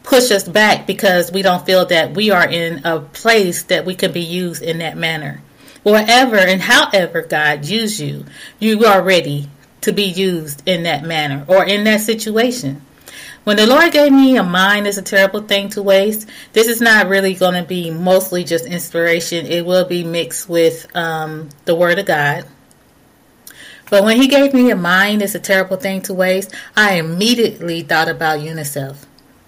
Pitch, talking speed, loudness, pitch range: 185 Hz, 185 wpm, -14 LUFS, 165-210 Hz